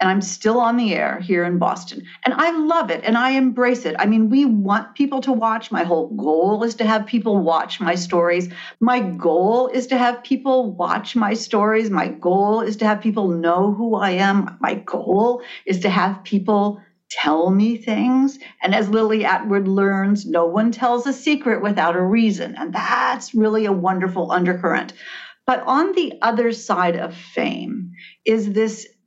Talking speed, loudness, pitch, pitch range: 185 wpm, -19 LUFS, 215 Hz, 190-240 Hz